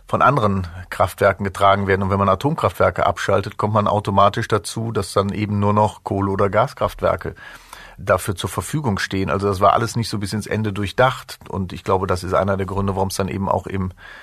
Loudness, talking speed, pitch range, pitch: -20 LUFS, 210 wpm, 95-105 Hz, 100 Hz